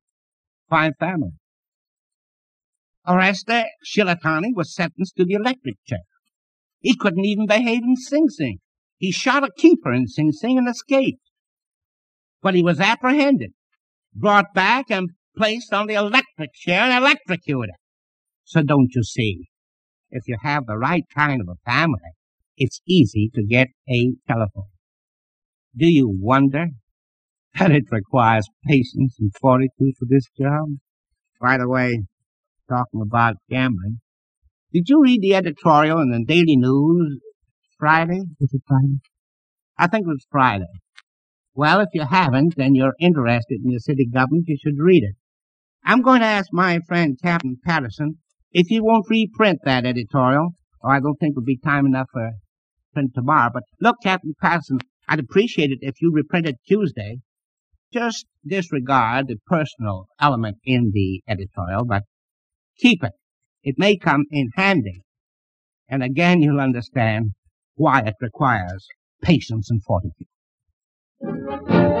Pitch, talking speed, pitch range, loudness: 140 Hz, 145 wpm, 120-180 Hz, -19 LUFS